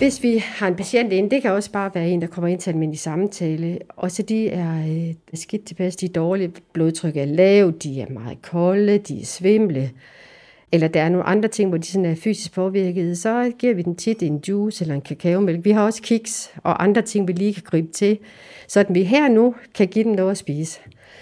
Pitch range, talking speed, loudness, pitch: 165-210 Hz, 225 wpm, -20 LUFS, 185 Hz